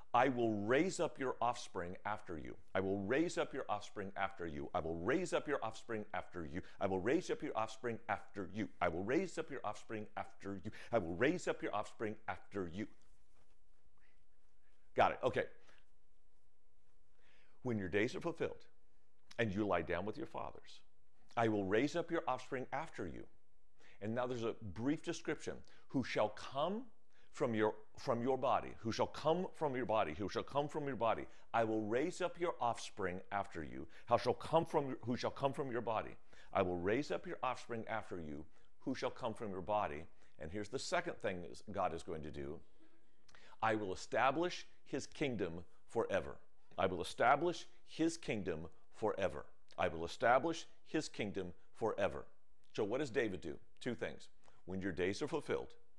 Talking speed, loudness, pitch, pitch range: 185 wpm, -40 LUFS, 110 Hz, 100-140 Hz